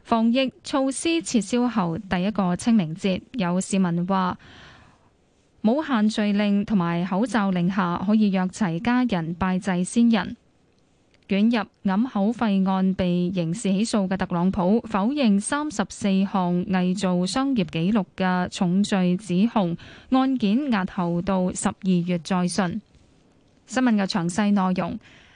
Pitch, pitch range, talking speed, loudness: 195 Hz, 185-225 Hz, 205 characters per minute, -23 LUFS